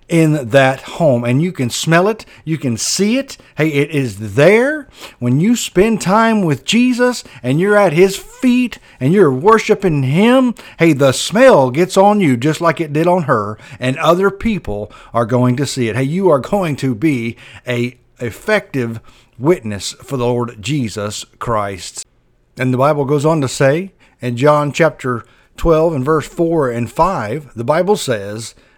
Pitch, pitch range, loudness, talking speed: 145 Hz, 125-185 Hz, -14 LUFS, 175 wpm